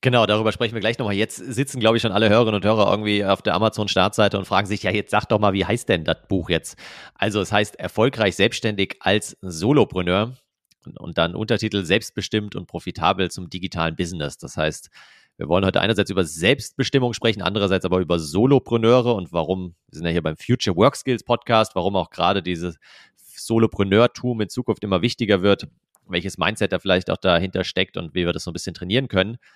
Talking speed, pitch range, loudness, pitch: 205 wpm, 95-115 Hz, -21 LUFS, 105 Hz